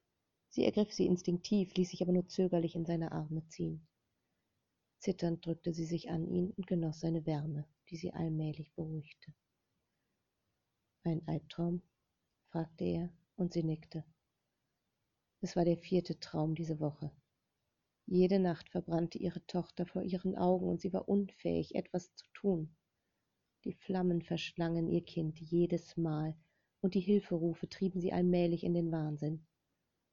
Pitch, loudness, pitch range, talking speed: 170 Hz, -37 LUFS, 155-180 Hz, 145 wpm